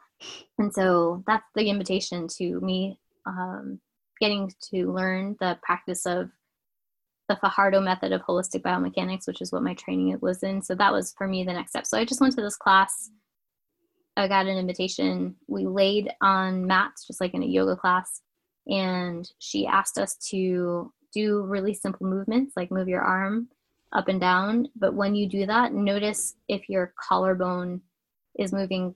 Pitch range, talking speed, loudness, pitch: 180-205 Hz, 170 wpm, -26 LUFS, 190 Hz